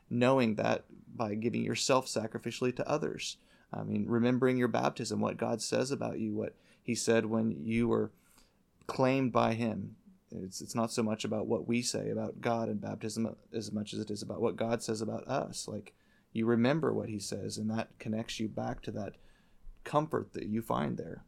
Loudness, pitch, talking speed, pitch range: -33 LUFS, 115 Hz, 195 wpm, 110-120 Hz